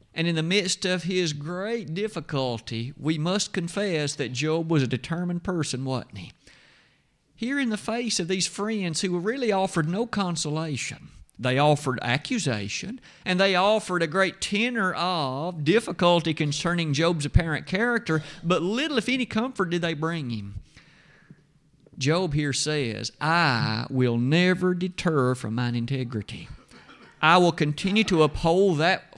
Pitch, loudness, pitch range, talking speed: 170 Hz, -25 LUFS, 145-190 Hz, 150 wpm